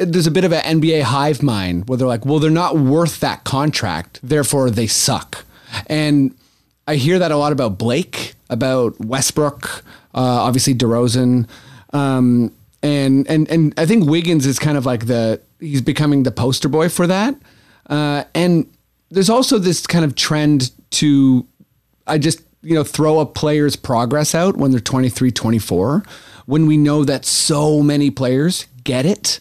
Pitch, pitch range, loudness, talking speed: 145 Hz, 130-155 Hz, -16 LUFS, 170 wpm